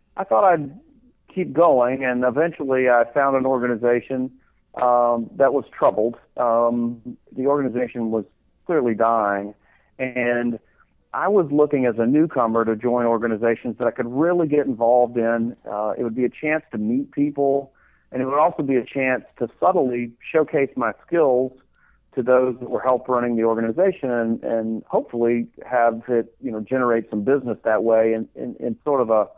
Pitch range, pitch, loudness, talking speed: 115-135 Hz, 125 Hz, -21 LUFS, 175 wpm